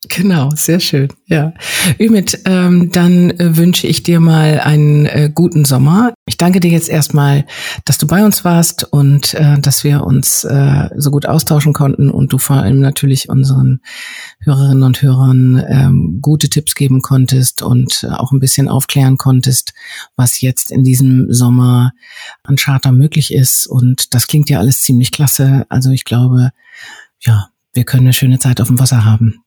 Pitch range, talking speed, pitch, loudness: 130-150 Hz, 170 wpm, 140 Hz, -10 LUFS